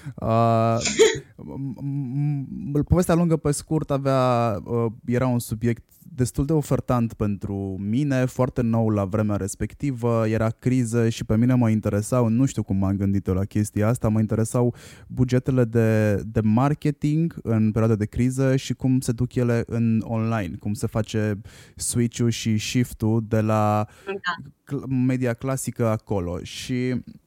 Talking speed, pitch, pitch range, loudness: 145 wpm, 120 Hz, 110-130 Hz, -23 LUFS